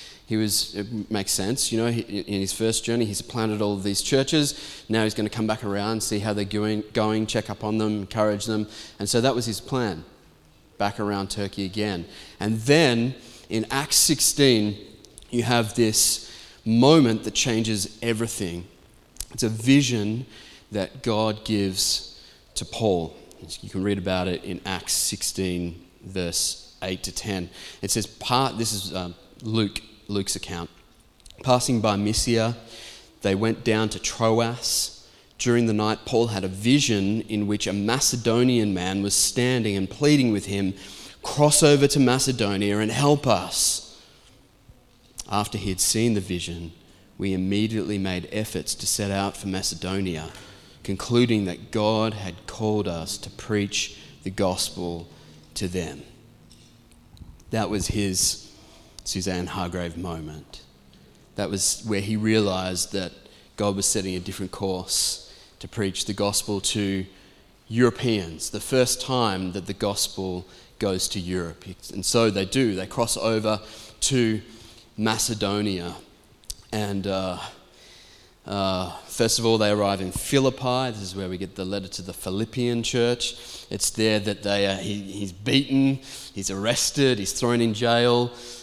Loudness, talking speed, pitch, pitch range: -24 LUFS, 150 wpm, 105 Hz, 95-115 Hz